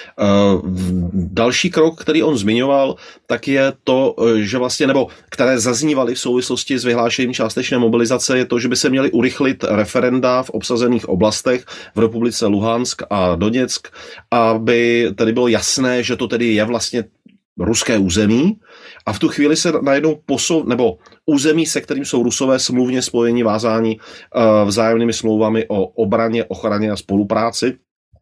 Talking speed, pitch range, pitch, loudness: 145 wpm, 110-130 Hz, 120 Hz, -16 LUFS